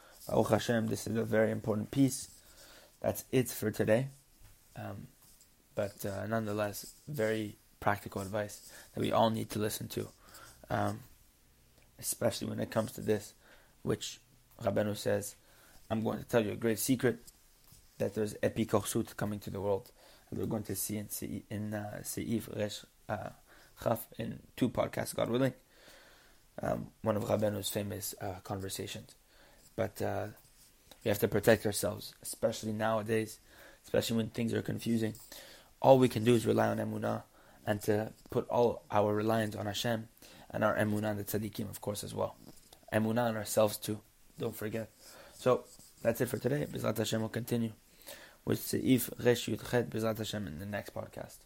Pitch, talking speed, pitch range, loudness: 110 Hz, 165 wpm, 105-115 Hz, -34 LUFS